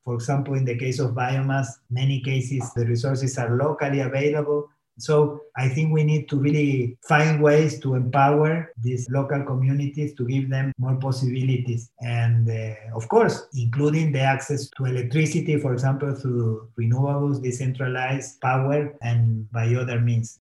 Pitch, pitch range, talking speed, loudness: 135 Hz, 125-145 Hz, 150 wpm, -23 LUFS